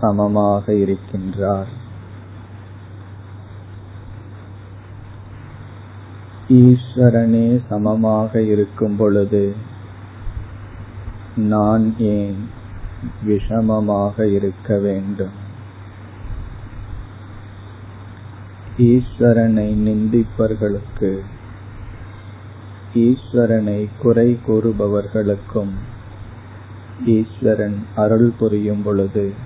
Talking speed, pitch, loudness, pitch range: 40 wpm, 105 Hz, -17 LUFS, 100-110 Hz